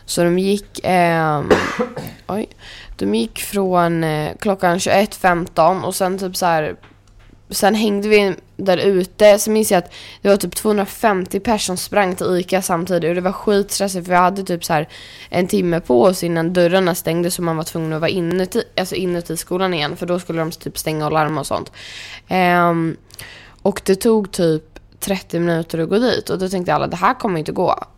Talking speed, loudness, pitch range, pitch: 195 wpm, -18 LUFS, 165-195 Hz, 180 Hz